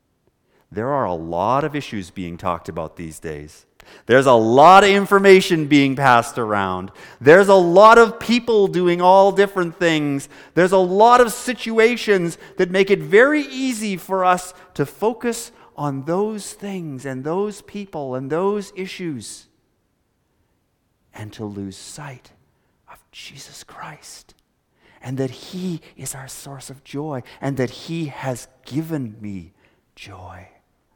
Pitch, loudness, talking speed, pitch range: 160 Hz, -17 LUFS, 140 wpm, 130-195 Hz